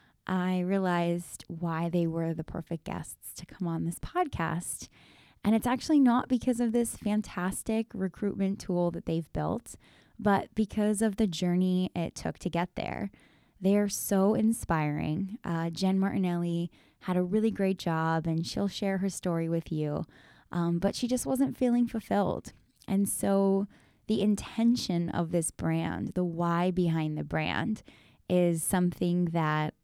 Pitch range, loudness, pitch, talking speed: 170-210 Hz, -30 LUFS, 185 Hz, 155 wpm